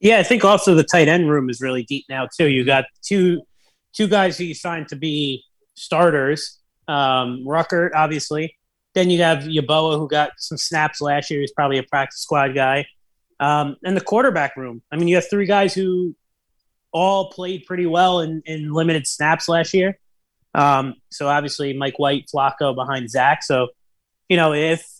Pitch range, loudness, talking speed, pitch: 140-175 Hz, -19 LUFS, 185 wpm, 155 Hz